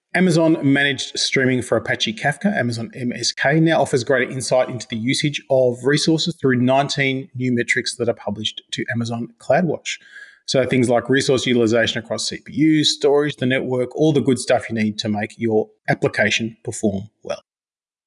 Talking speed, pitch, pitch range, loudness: 165 wpm, 130 Hz, 115-140 Hz, -19 LUFS